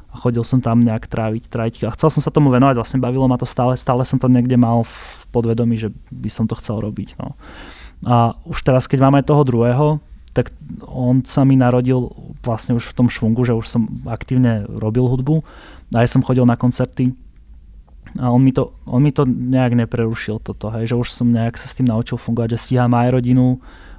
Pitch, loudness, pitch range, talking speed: 120 Hz, -17 LUFS, 115-130 Hz, 210 wpm